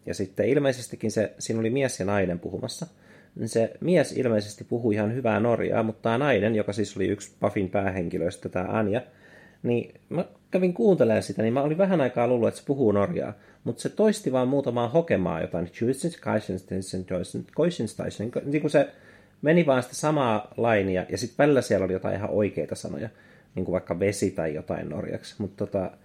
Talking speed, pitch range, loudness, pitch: 175 wpm, 100-130 Hz, -26 LUFS, 110 Hz